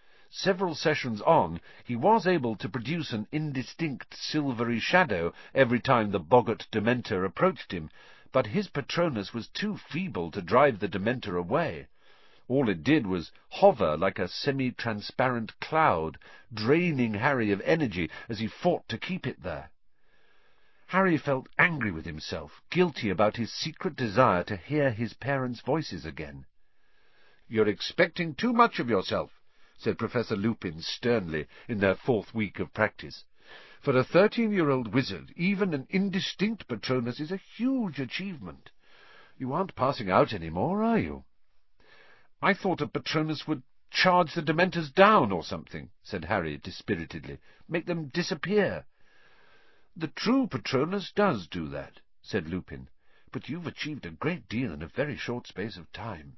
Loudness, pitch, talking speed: -28 LUFS, 135 Hz, 150 wpm